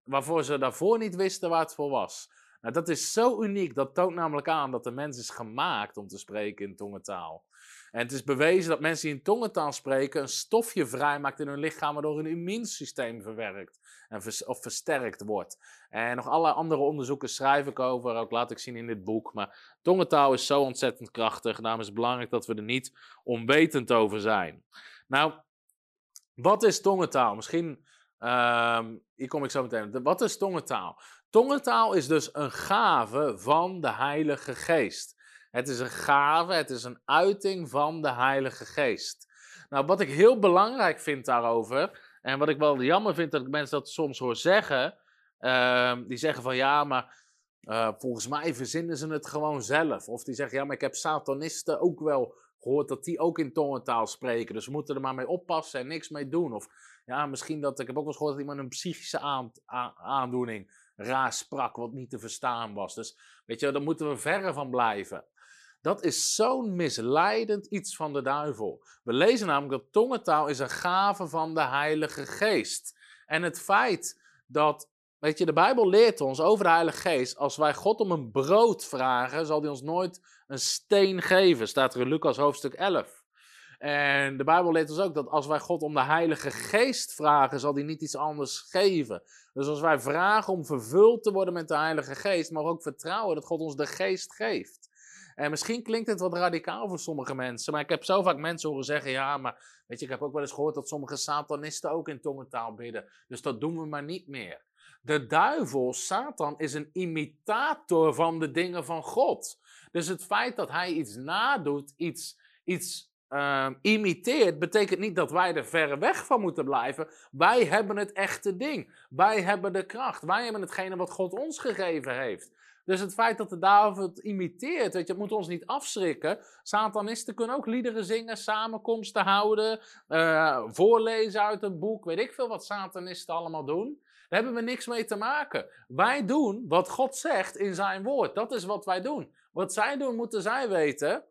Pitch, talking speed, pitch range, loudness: 155 Hz, 195 wpm, 135-190 Hz, -28 LUFS